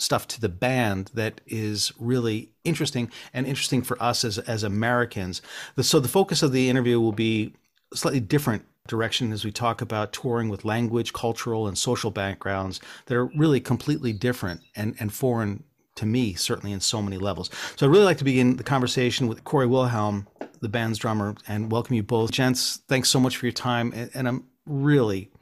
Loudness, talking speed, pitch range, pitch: -25 LUFS, 195 wpm, 110-130 Hz, 120 Hz